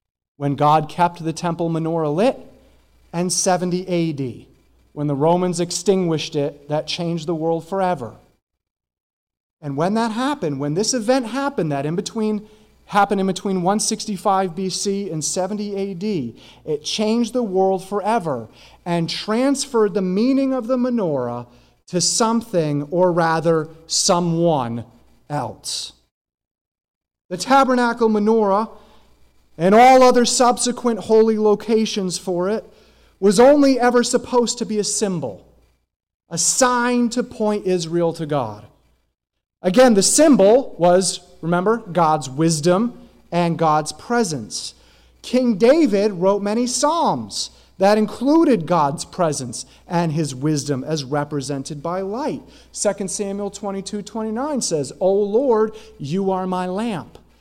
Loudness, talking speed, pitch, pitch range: -19 LUFS, 130 wpm, 190 Hz, 160-220 Hz